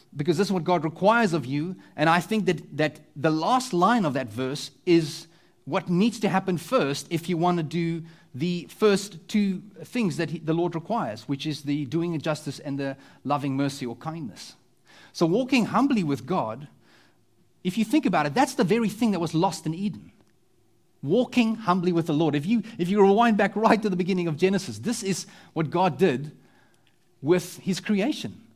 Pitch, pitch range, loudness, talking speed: 175 Hz, 160-200 Hz, -25 LUFS, 200 wpm